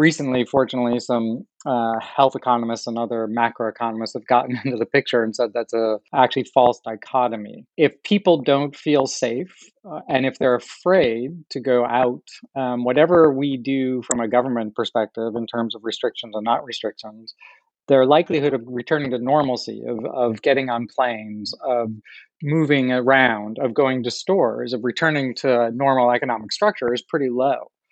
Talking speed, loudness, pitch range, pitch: 165 wpm, -20 LUFS, 115-135 Hz, 125 Hz